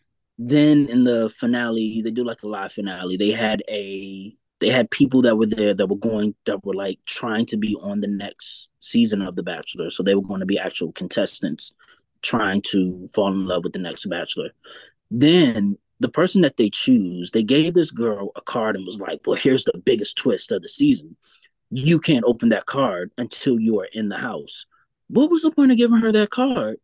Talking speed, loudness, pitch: 210 wpm, -21 LUFS, 115 Hz